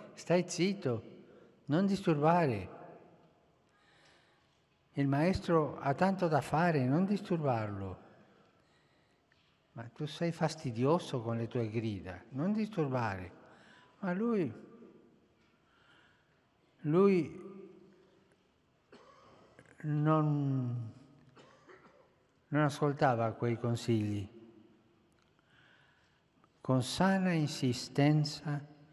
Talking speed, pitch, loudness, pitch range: 70 wpm, 145 Hz, -33 LUFS, 120-175 Hz